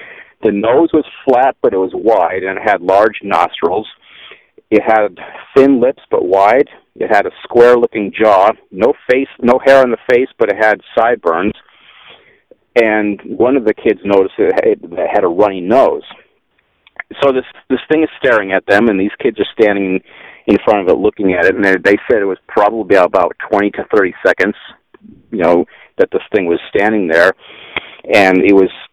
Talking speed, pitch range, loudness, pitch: 185 wpm, 100-155 Hz, -12 LUFS, 125 Hz